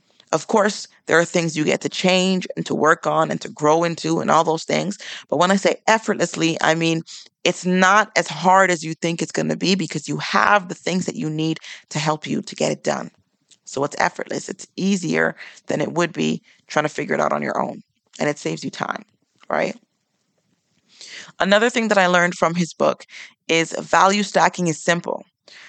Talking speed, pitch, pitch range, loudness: 210 wpm, 175 Hz, 160-190 Hz, -20 LUFS